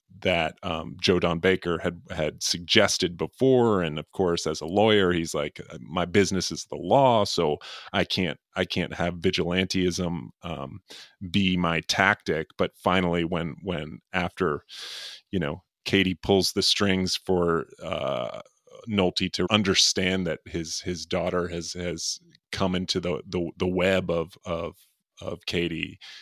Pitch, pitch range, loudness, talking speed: 90 Hz, 85-95 Hz, -25 LUFS, 150 wpm